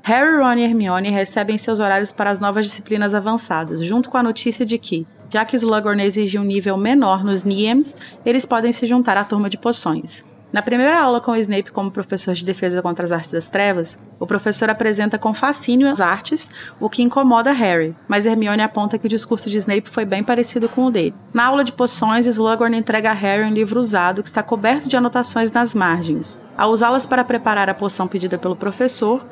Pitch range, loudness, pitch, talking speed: 200-240 Hz, -18 LUFS, 220 Hz, 205 wpm